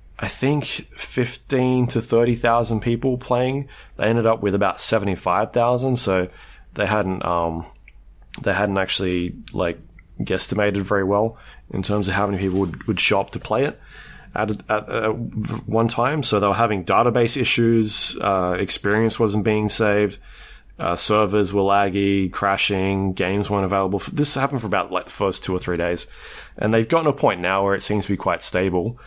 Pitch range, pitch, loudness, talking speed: 95-115 Hz, 105 Hz, -21 LUFS, 180 wpm